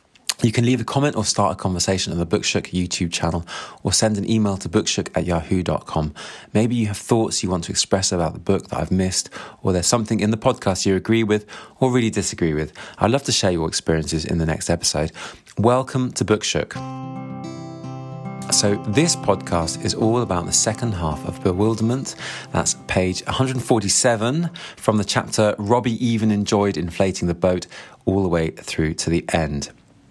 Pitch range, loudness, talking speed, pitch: 85-115 Hz, -21 LUFS, 185 wpm, 100 Hz